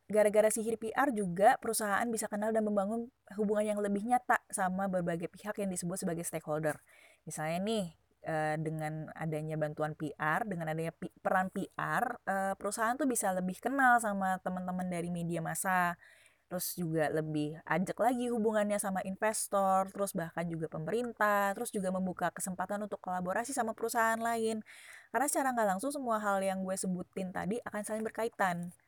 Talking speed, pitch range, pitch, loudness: 155 wpm, 175-220 Hz, 195 Hz, -33 LUFS